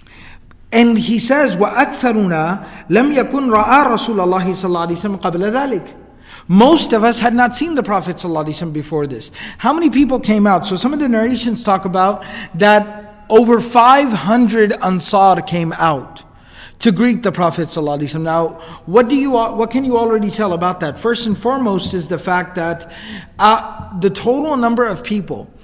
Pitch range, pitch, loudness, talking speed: 180-235 Hz, 210 Hz, -14 LUFS, 145 wpm